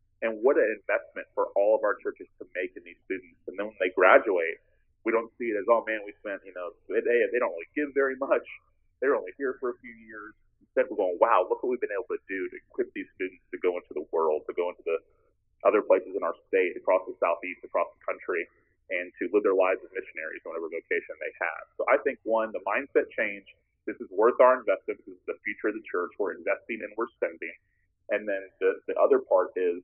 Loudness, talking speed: -28 LUFS, 245 wpm